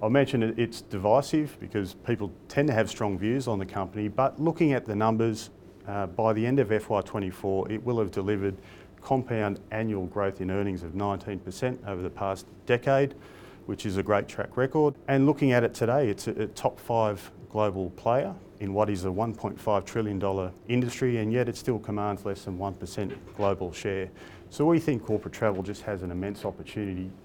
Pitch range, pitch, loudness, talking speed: 100-120 Hz, 105 Hz, -28 LUFS, 185 wpm